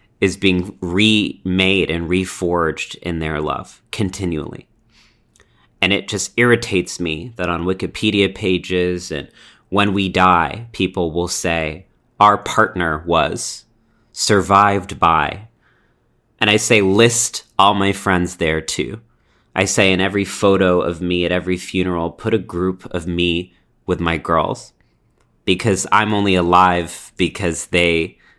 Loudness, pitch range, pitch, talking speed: -17 LUFS, 90-100 Hz, 95 Hz, 135 wpm